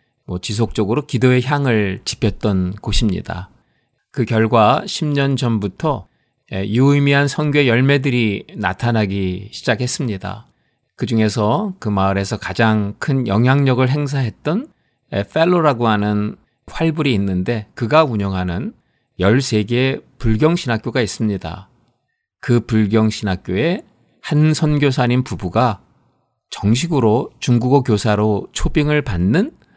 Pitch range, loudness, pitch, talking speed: 105-135 Hz, -17 LUFS, 115 Hz, 255 characters per minute